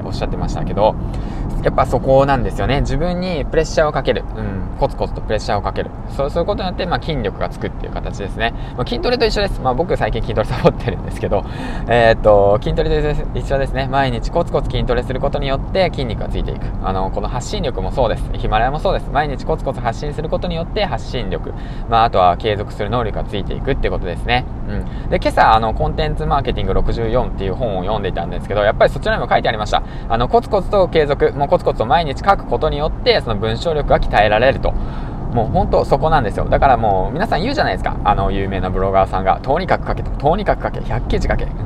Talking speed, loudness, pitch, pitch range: 515 characters per minute, -18 LUFS, 125 Hz, 105-150 Hz